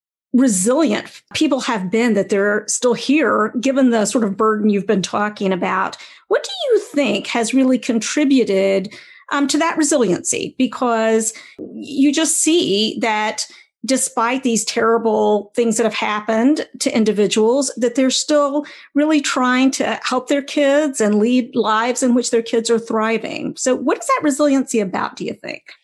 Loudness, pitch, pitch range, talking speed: -17 LUFS, 245 Hz, 220-275 Hz, 160 wpm